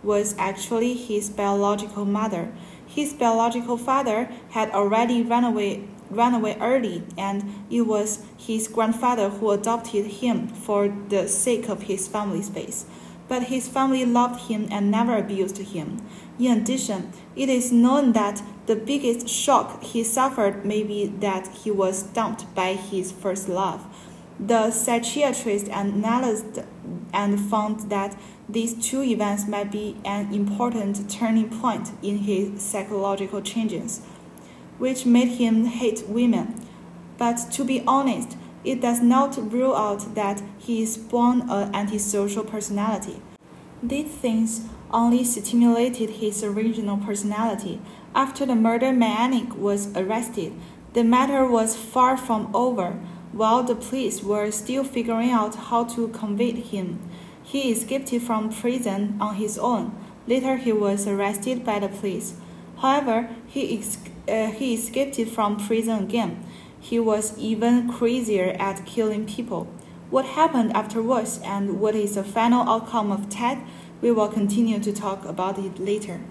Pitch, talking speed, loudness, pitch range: 220 Hz, 140 wpm, -24 LUFS, 205-240 Hz